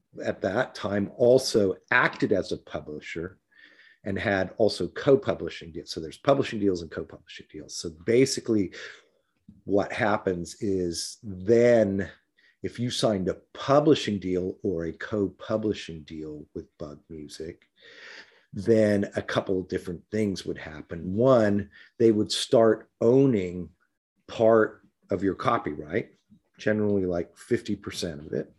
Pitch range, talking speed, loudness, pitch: 90-110 Hz, 135 wpm, -26 LUFS, 100 Hz